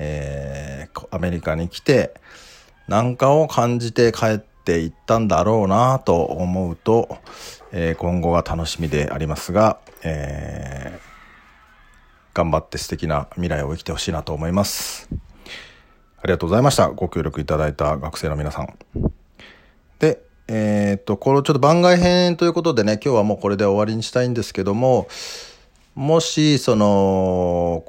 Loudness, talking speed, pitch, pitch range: -20 LUFS, 300 characters per minute, 95 Hz, 80-115 Hz